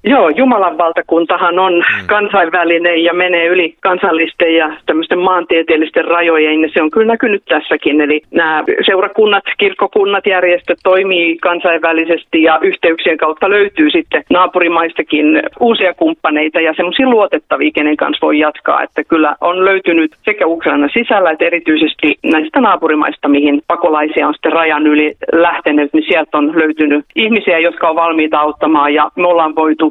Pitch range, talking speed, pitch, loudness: 155-185 Hz, 145 wpm, 165 Hz, -11 LUFS